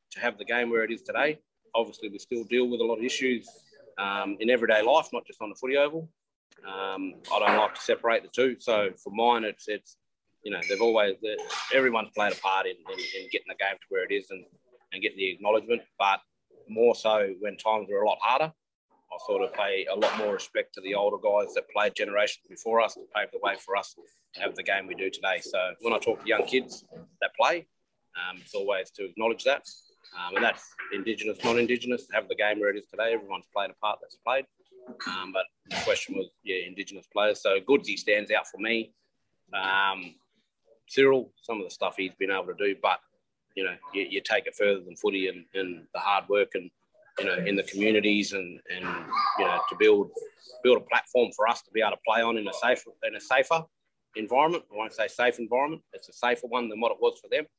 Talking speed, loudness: 230 wpm, -28 LUFS